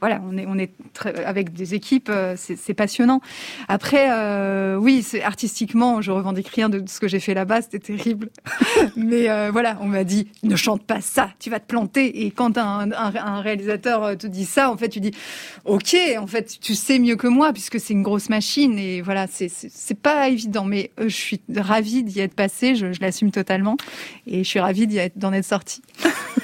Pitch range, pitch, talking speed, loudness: 195-235 Hz, 210 Hz, 220 wpm, -21 LUFS